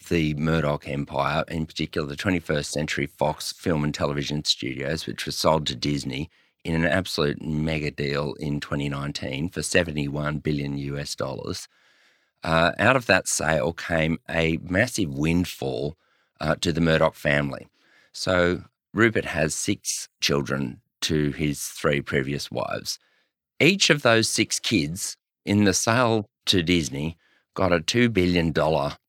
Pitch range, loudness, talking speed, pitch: 70-90 Hz, -24 LUFS, 140 wpm, 80 Hz